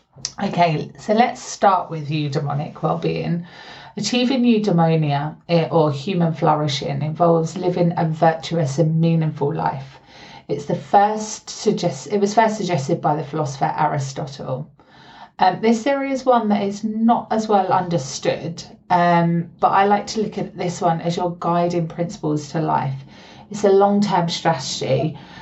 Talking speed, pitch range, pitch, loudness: 145 wpm, 160-205 Hz, 170 Hz, -20 LUFS